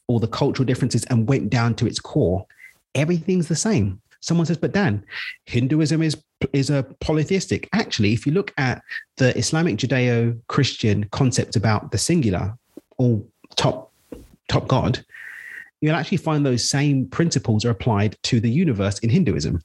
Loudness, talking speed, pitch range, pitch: -21 LUFS, 155 wpm, 115-155 Hz, 130 Hz